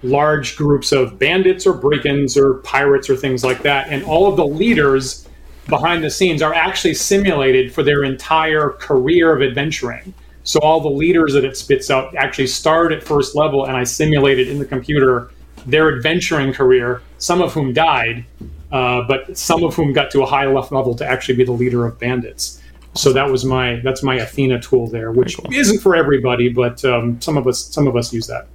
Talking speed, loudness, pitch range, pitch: 200 wpm, -15 LUFS, 125-155 Hz, 135 Hz